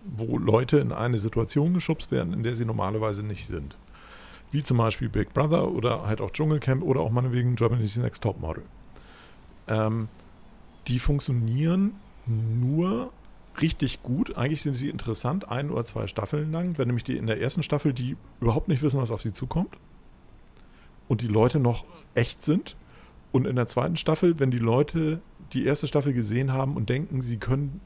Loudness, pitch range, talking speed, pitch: -27 LUFS, 115-150 Hz, 175 wpm, 125 Hz